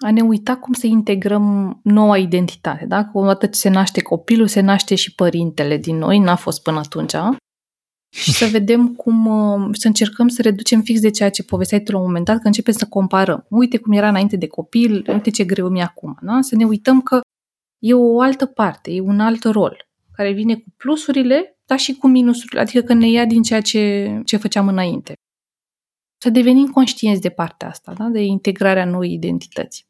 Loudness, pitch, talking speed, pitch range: -16 LUFS, 215 Hz, 205 wpm, 195-235 Hz